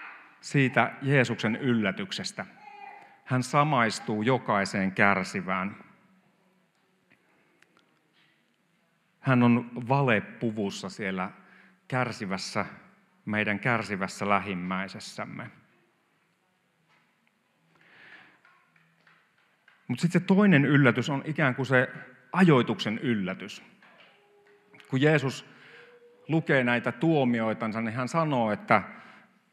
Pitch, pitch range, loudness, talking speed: 130 Hz, 115-160 Hz, -27 LUFS, 70 wpm